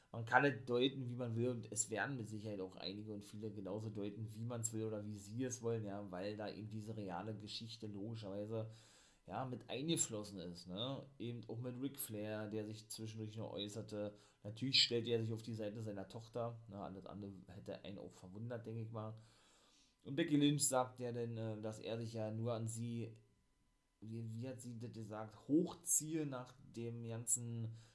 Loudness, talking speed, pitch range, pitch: -43 LUFS, 195 wpm, 105-120 Hz, 110 Hz